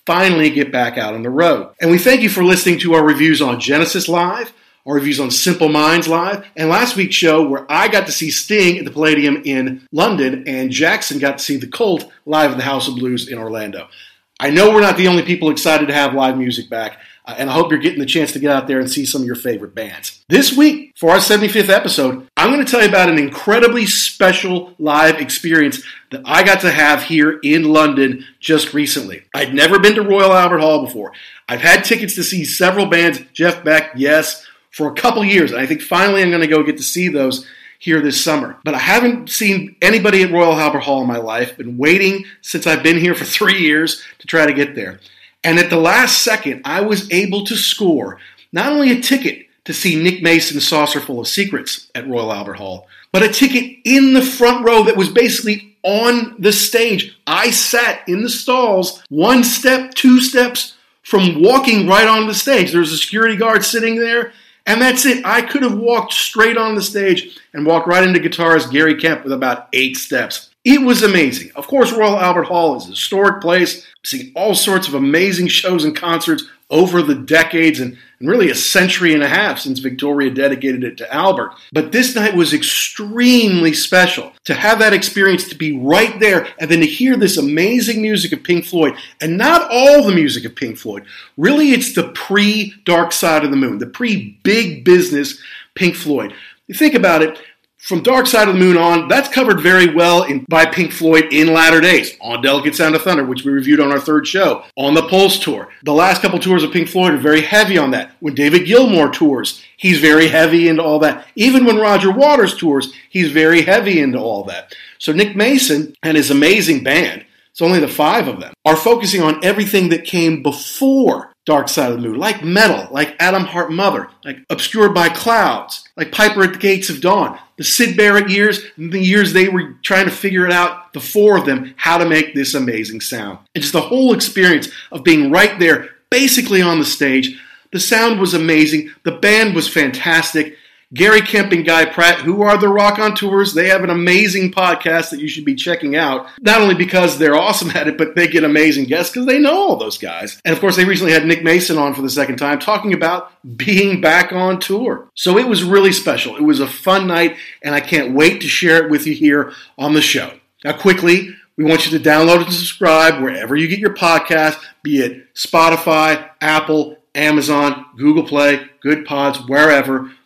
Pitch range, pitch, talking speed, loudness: 150-205 Hz, 175 Hz, 215 wpm, -13 LUFS